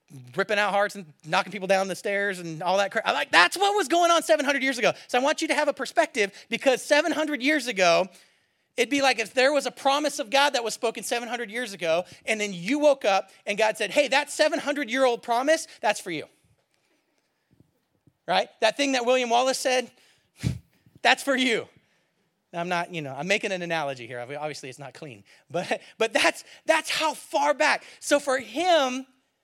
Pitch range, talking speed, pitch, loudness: 195-285 Hz, 200 wpm, 245 Hz, -24 LUFS